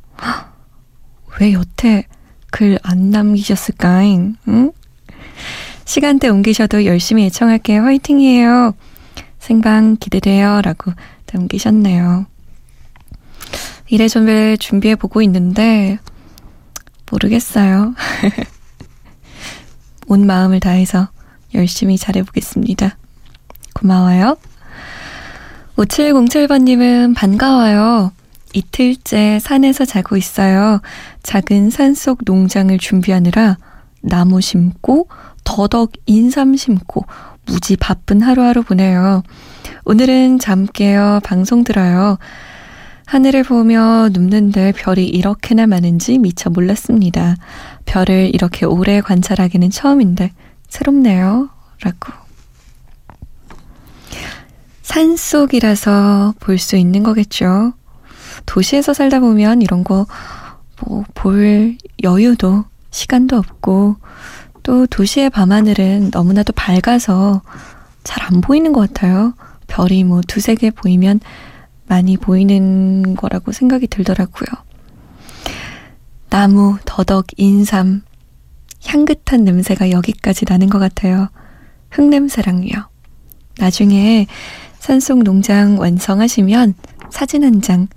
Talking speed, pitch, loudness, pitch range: 215 characters per minute, 205 Hz, -12 LUFS, 190-235 Hz